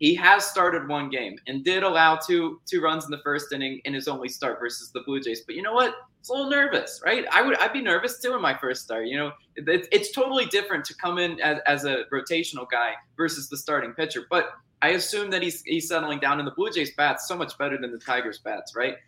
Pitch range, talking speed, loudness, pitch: 140-200 Hz, 255 wpm, -25 LUFS, 160 Hz